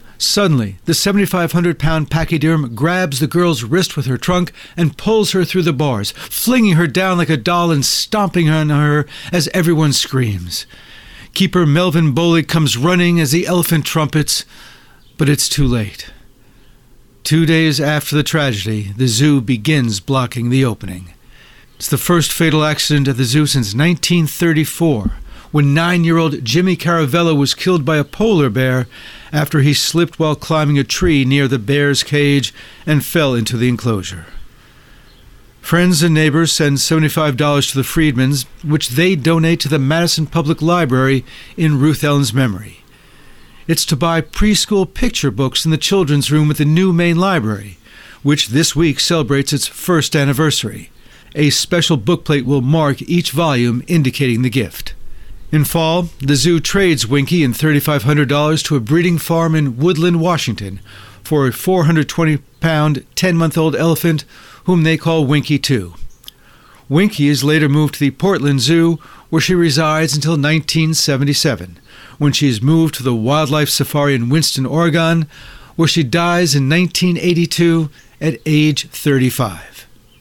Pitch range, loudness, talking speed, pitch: 135-165 Hz, -14 LUFS, 155 wpm, 150 Hz